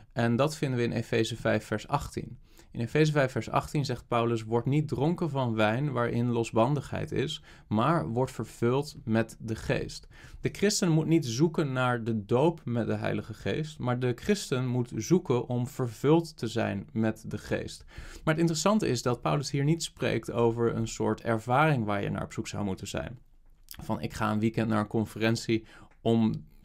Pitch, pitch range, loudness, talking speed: 120 Hz, 110-145 Hz, -29 LUFS, 190 wpm